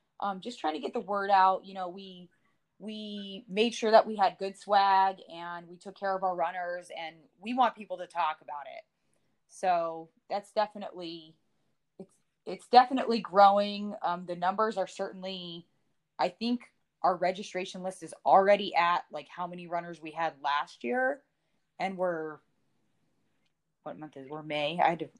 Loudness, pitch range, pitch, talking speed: -29 LUFS, 170-205 Hz, 185 Hz, 175 wpm